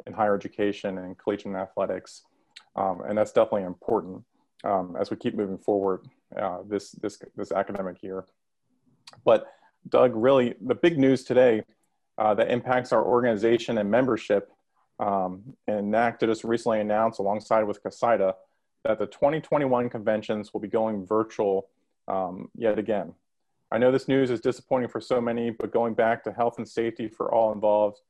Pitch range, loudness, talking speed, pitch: 100-120 Hz, -26 LUFS, 160 wpm, 110 Hz